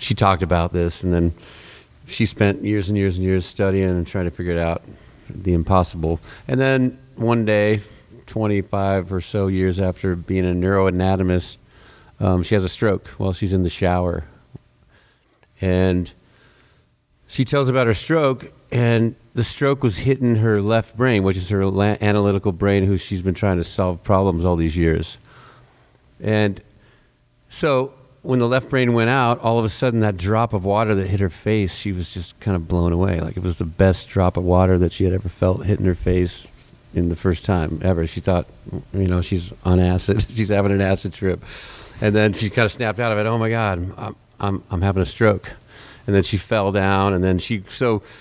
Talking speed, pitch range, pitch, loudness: 200 wpm, 90-110 Hz, 100 Hz, -20 LUFS